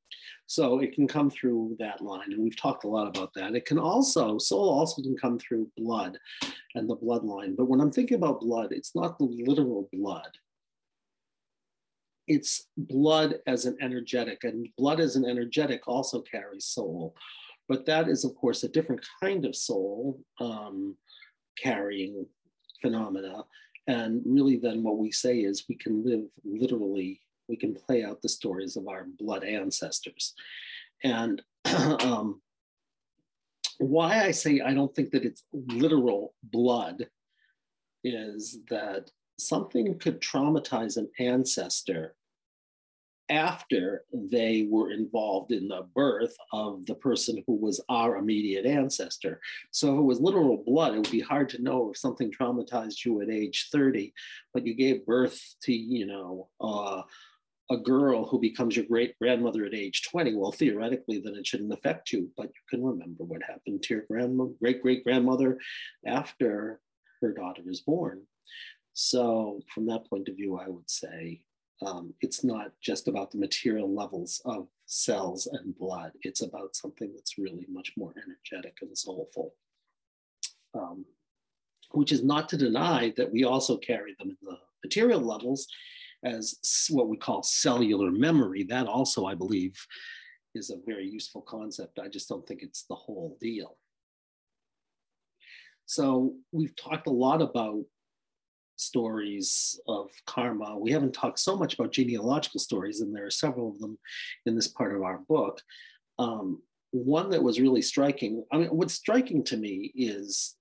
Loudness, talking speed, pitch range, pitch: -29 LUFS, 155 wpm, 110-140 Hz, 125 Hz